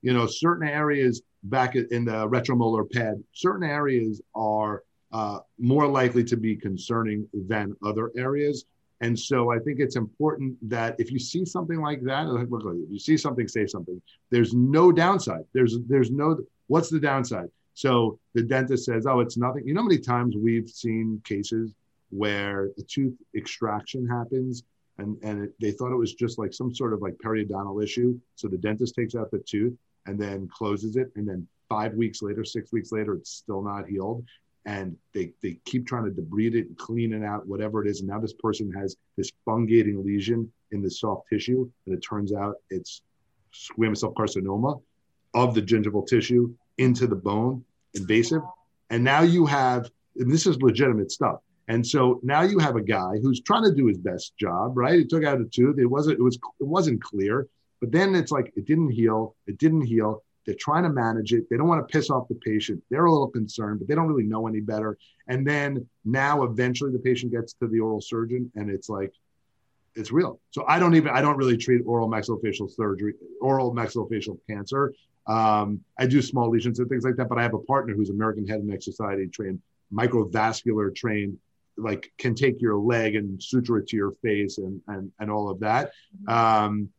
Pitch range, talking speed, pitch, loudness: 105-130 Hz, 200 wpm, 115 Hz, -25 LUFS